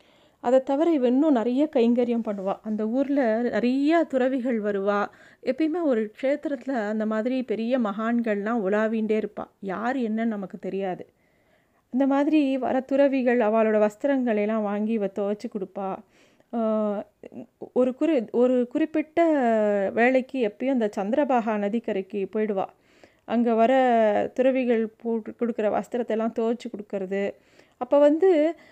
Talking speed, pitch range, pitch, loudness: 115 wpm, 215-265 Hz, 235 Hz, -24 LUFS